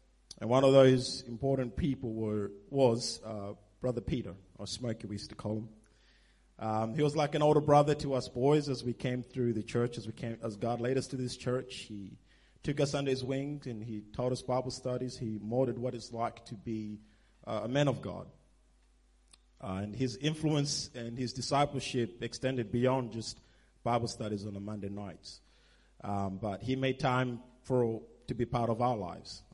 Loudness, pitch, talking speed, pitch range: -33 LUFS, 120 Hz, 195 wpm, 110-130 Hz